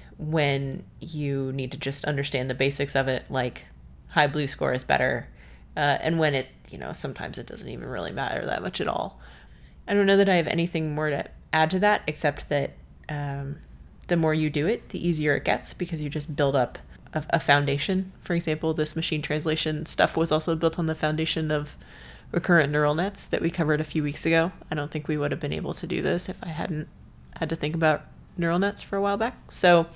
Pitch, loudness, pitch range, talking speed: 155 Hz, -26 LUFS, 140-165 Hz, 225 wpm